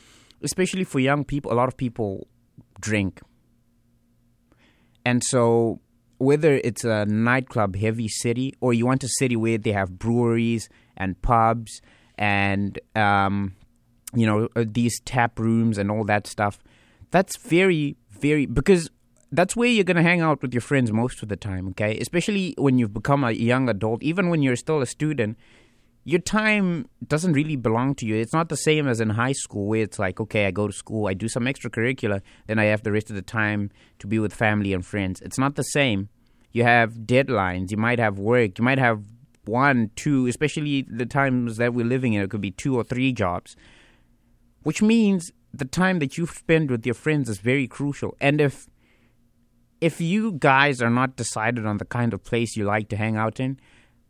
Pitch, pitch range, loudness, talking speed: 120 Hz, 110-135 Hz, -23 LUFS, 195 wpm